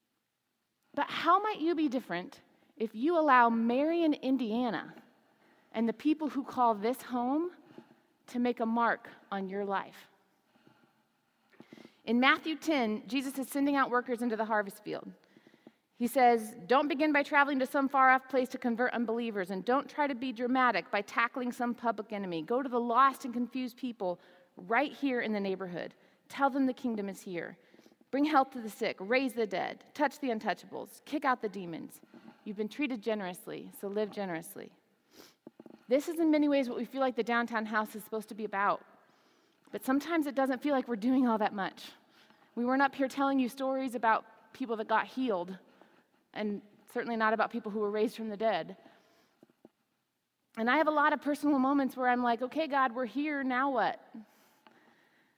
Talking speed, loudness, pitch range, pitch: 185 wpm, -31 LUFS, 220-275 Hz, 245 Hz